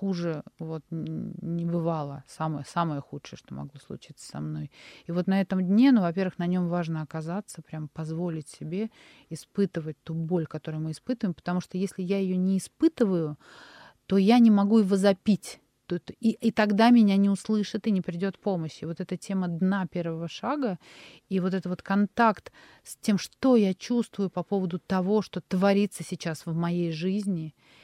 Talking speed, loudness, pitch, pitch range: 175 wpm, -27 LUFS, 185 Hz, 165-200 Hz